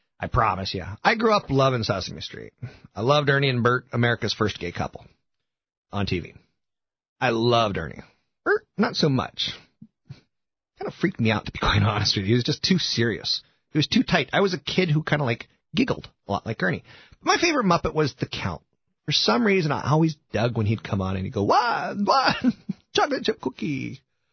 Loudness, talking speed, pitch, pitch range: -23 LUFS, 205 wpm, 130 Hz, 105-170 Hz